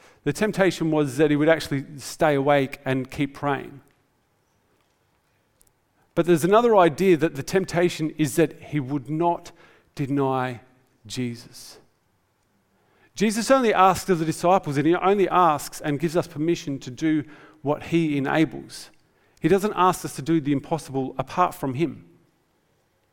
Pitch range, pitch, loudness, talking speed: 135-170 Hz, 150 Hz, -23 LUFS, 145 wpm